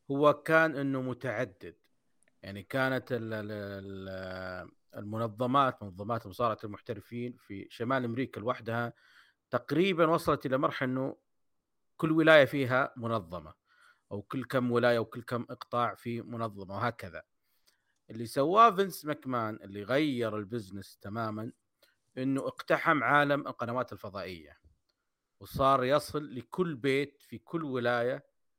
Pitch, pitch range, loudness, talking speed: 120 Hz, 110-135 Hz, -31 LUFS, 110 wpm